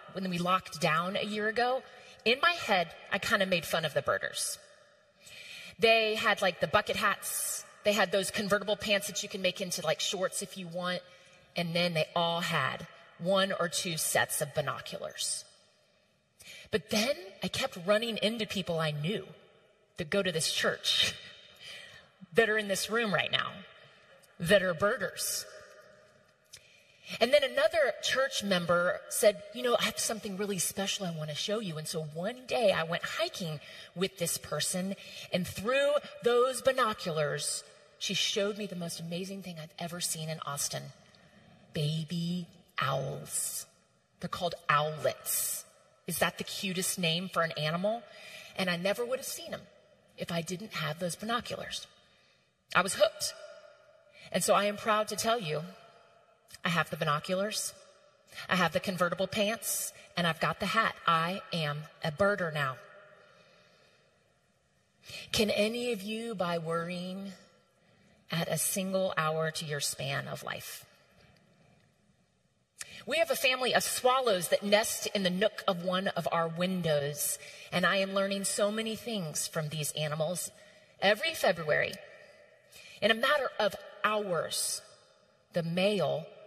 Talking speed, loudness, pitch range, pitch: 155 wpm, -31 LUFS, 170-215 Hz, 195 Hz